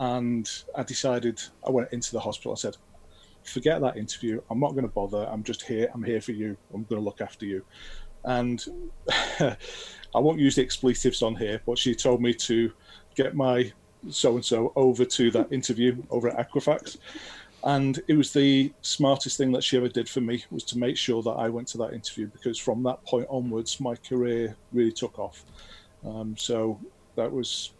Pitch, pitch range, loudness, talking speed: 120 Hz, 115-130 Hz, -27 LUFS, 200 wpm